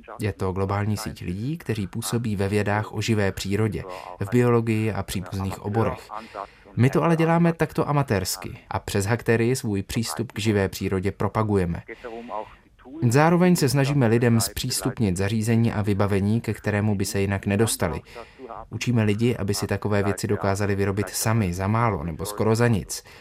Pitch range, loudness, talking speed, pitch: 100-115 Hz, -24 LUFS, 160 wpm, 110 Hz